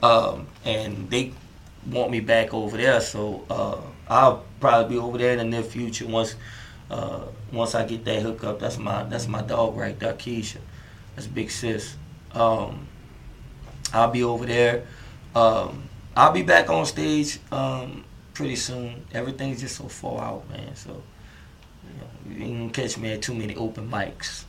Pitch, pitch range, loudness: 115 Hz, 110-120 Hz, -24 LUFS